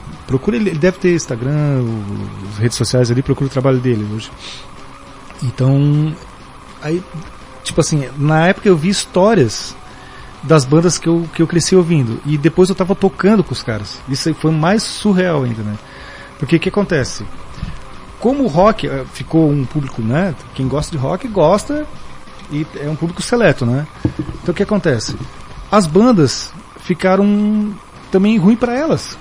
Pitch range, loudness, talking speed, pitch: 130-190 Hz, -15 LUFS, 160 wpm, 160 Hz